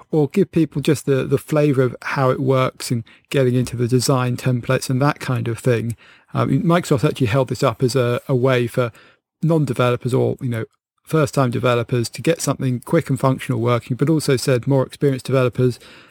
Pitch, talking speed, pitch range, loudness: 130 Hz, 195 wpm, 125-145 Hz, -19 LUFS